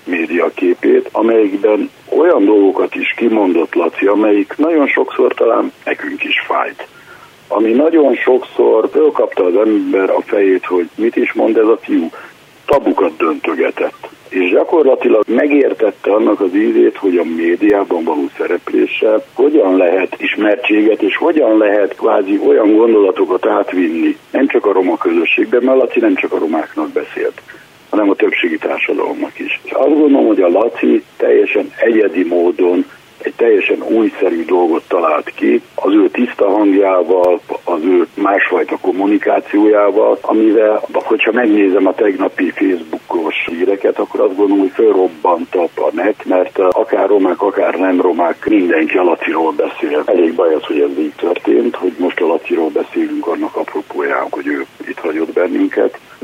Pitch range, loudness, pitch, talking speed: 315-430 Hz, -13 LUFS, 360 Hz, 145 wpm